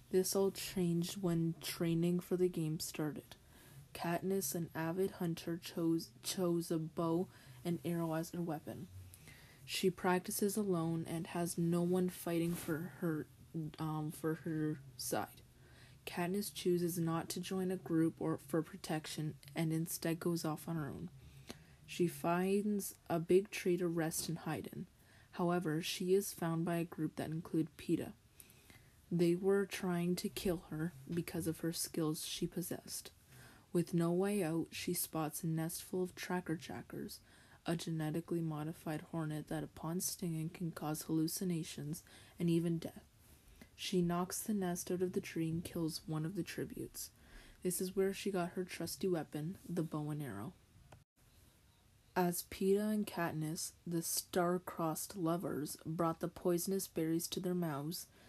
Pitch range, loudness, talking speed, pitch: 155-180 Hz, -39 LUFS, 155 wpm, 170 Hz